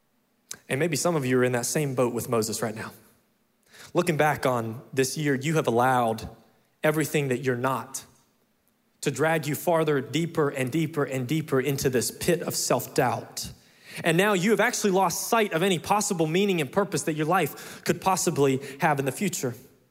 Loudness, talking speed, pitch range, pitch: -25 LUFS, 190 wpm, 130-180 Hz, 150 Hz